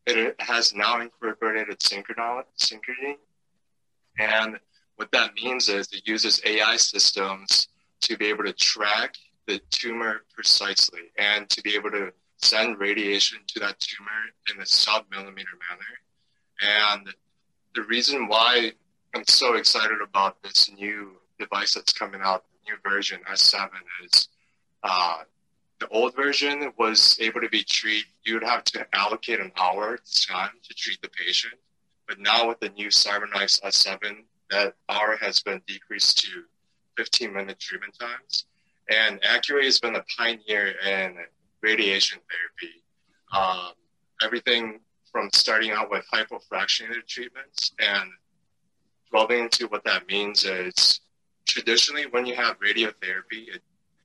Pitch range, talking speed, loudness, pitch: 100-115 Hz, 135 wpm, -22 LUFS, 110 Hz